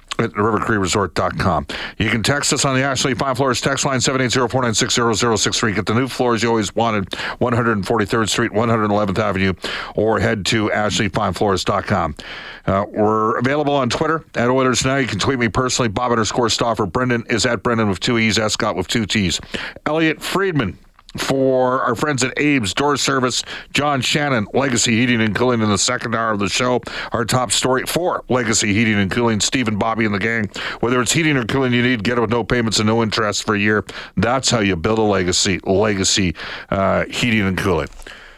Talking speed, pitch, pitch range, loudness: 190 wpm, 115 Hz, 105-130 Hz, -18 LUFS